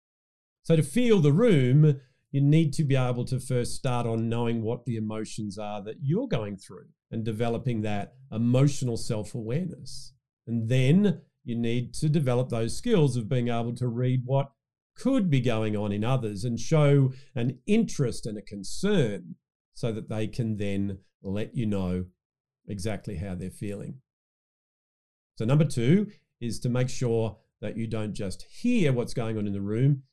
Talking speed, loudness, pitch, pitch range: 170 wpm, -27 LUFS, 120 Hz, 110-140 Hz